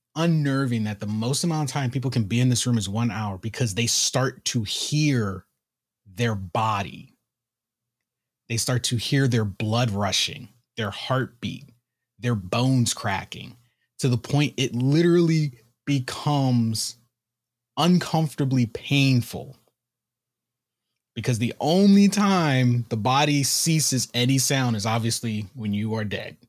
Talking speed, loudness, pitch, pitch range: 130 wpm, -23 LUFS, 120 Hz, 115-135 Hz